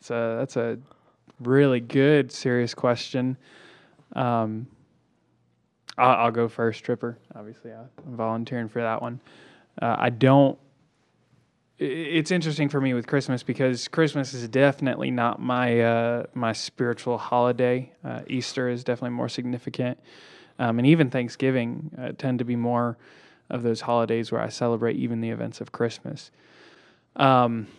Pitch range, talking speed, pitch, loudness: 115-130 Hz, 140 wpm, 125 Hz, -25 LUFS